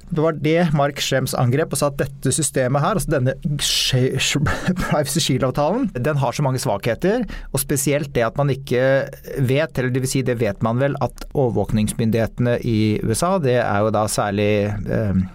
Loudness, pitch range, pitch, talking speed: -20 LUFS, 120-150 Hz, 130 Hz, 180 wpm